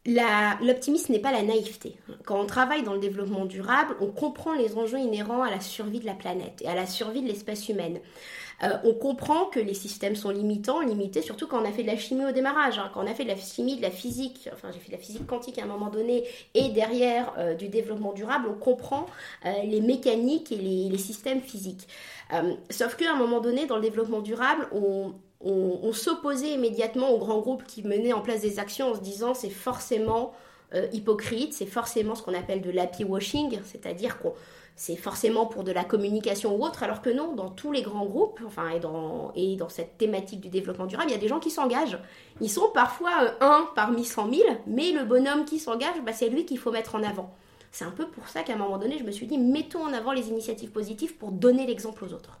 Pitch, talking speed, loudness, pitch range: 225 Hz, 235 wpm, -28 LUFS, 200-255 Hz